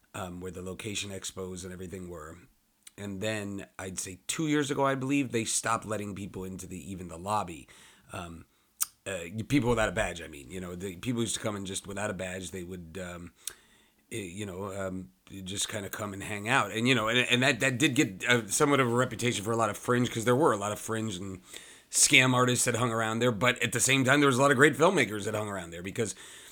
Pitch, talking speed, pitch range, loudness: 105 Hz, 245 wpm, 95-125 Hz, -28 LUFS